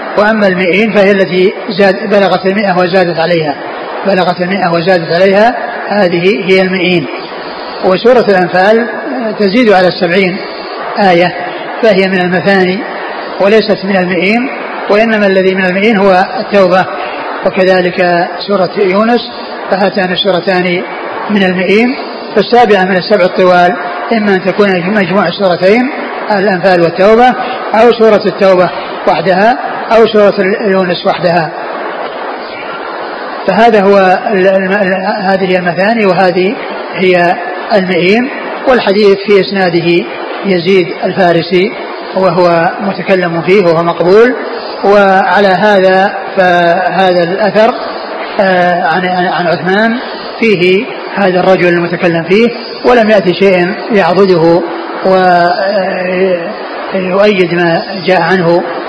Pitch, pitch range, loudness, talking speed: 190 Hz, 180-205 Hz, -9 LUFS, 100 wpm